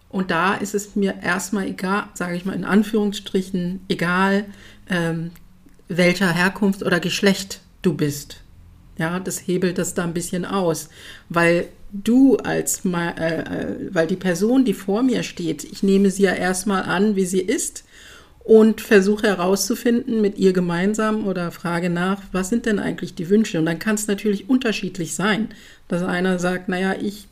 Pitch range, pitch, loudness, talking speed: 175-205 Hz, 190 Hz, -20 LUFS, 165 wpm